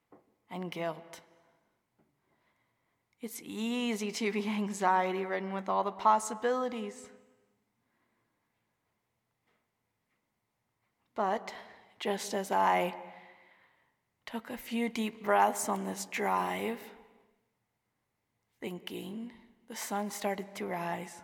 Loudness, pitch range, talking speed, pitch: -33 LUFS, 180-225 Hz, 85 wpm, 205 Hz